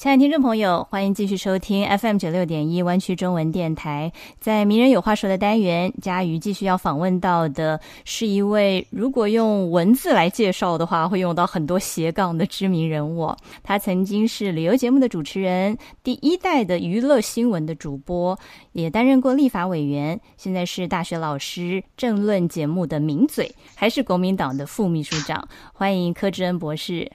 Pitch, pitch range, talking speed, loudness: 185 Hz, 170-210 Hz, 285 characters per minute, -21 LUFS